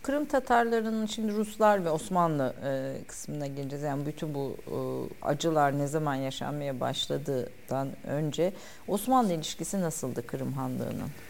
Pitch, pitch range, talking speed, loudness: 150 Hz, 140-200 Hz, 115 wpm, -30 LUFS